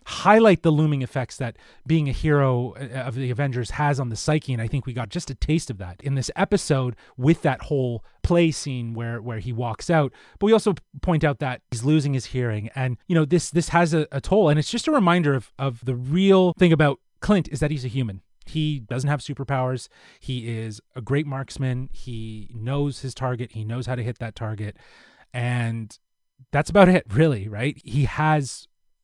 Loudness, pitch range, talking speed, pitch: -23 LUFS, 120-155 Hz, 210 wpm, 135 Hz